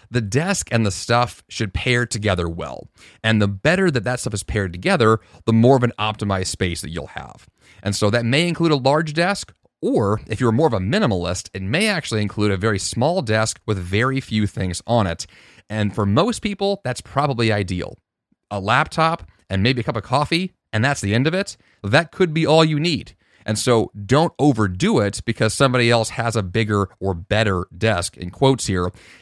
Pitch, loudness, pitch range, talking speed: 110 Hz, -20 LUFS, 100-135 Hz, 205 wpm